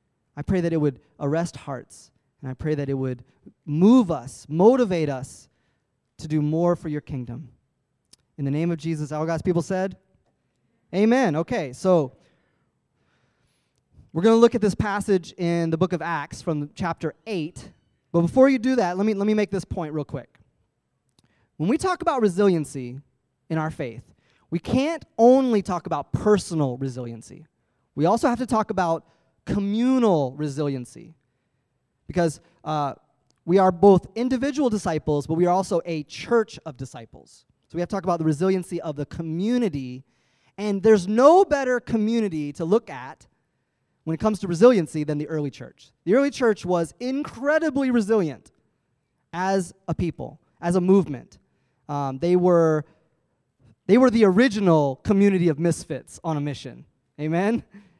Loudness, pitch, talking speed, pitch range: -23 LUFS, 165 Hz, 160 wpm, 140-205 Hz